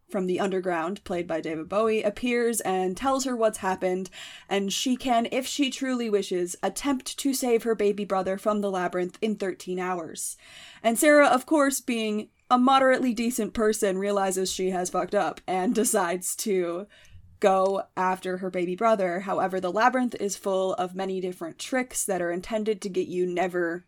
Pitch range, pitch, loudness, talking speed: 185-230 Hz, 195 Hz, -26 LUFS, 175 wpm